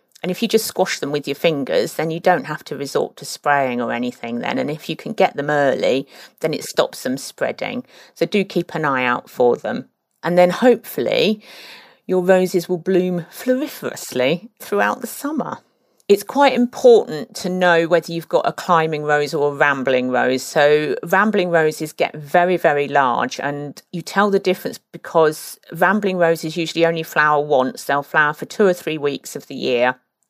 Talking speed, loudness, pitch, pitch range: 190 wpm, -18 LUFS, 165 Hz, 145-190 Hz